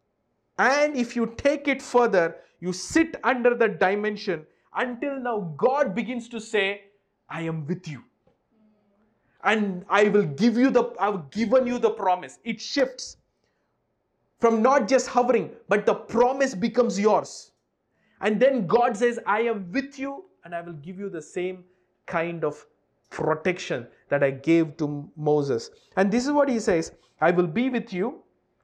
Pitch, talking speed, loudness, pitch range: 215 Hz, 165 wpm, -24 LUFS, 180-245 Hz